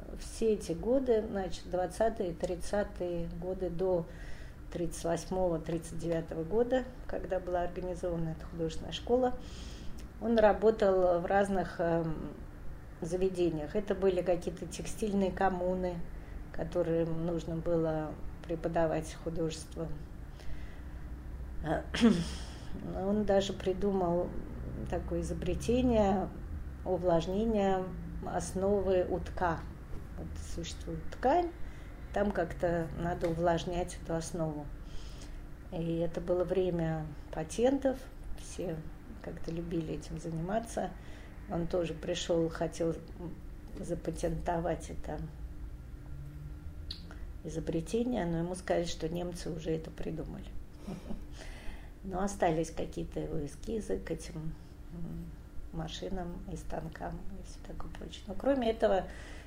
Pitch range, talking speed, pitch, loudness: 155-185 Hz, 90 wpm, 170 Hz, -34 LUFS